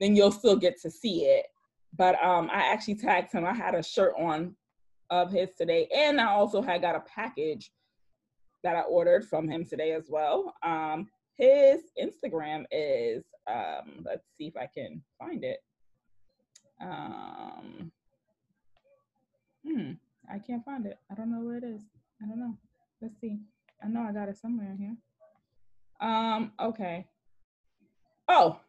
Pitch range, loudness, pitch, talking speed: 180-275 Hz, -28 LUFS, 220 Hz, 155 wpm